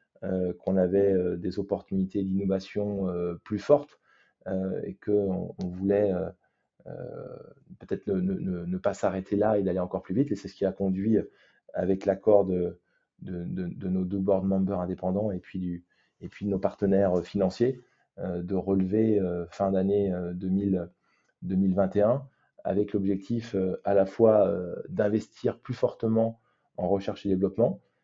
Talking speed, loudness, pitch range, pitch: 165 wpm, -28 LUFS, 95-105 Hz, 100 Hz